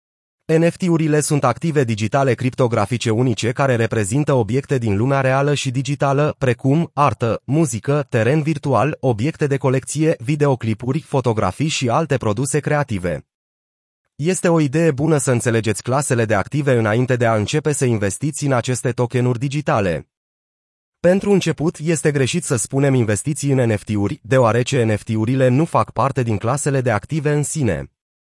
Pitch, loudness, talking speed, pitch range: 135 Hz, -18 LUFS, 140 wpm, 115-150 Hz